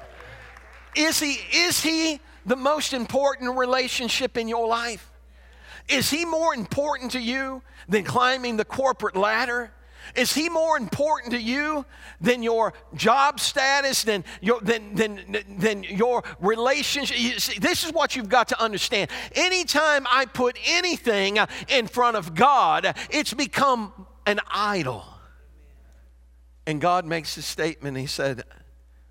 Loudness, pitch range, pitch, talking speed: -23 LUFS, 195-275 Hz, 240 Hz, 140 wpm